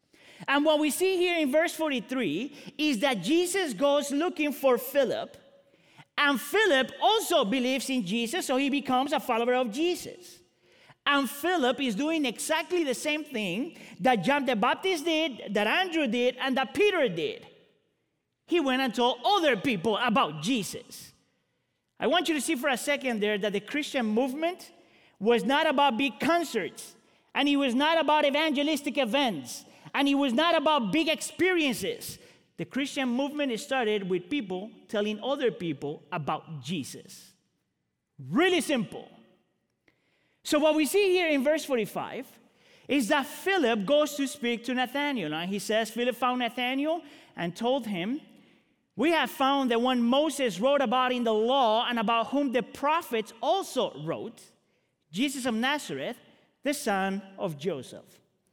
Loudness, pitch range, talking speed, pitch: -27 LUFS, 240-305 Hz, 155 wpm, 270 Hz